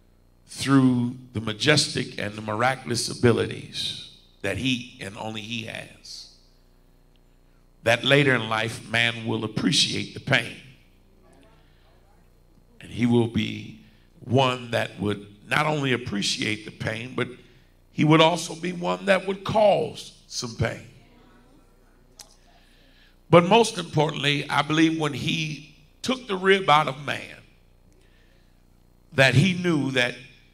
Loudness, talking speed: -23 LUFS, 120 wpm